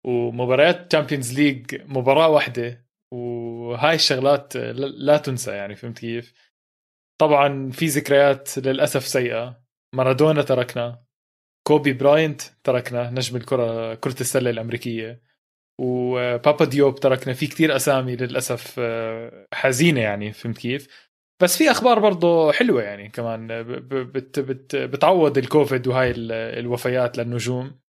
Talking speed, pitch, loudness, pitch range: 110 wpm, 130 Hz, -21 LUFS, 120-140 Hz